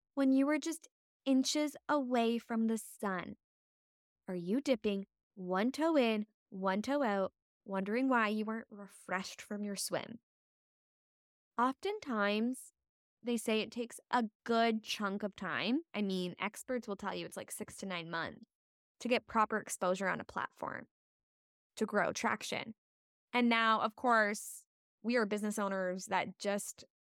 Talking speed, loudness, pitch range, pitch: 150 wpm, -35 LUFS, 195-245 Hz, 220 Hz